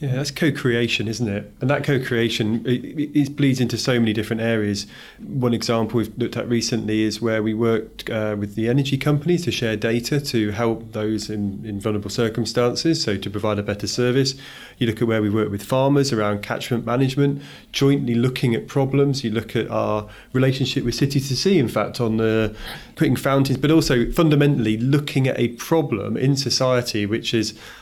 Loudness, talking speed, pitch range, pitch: -21 LUFS, 190 wpm, 110-135 Hz, 120 Hz